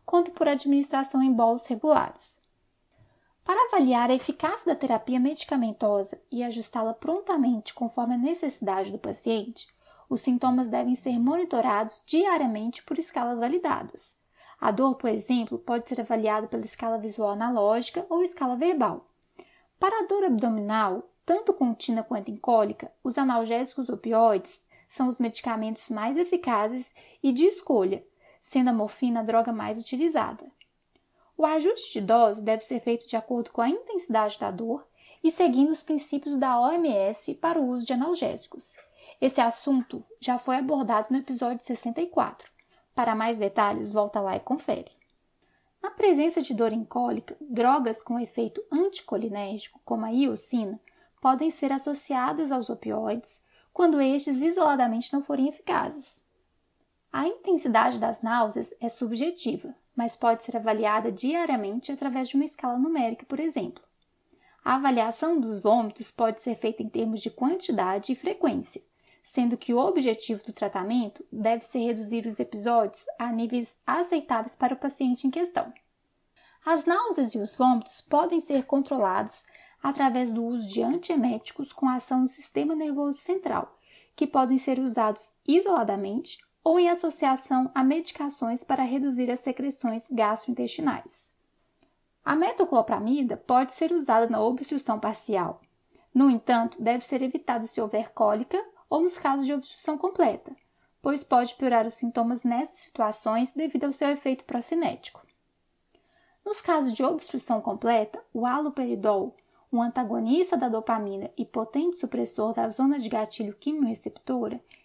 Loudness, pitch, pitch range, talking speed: -27 LUFS, 255 Hz, 230-315 Hz, 140 wpm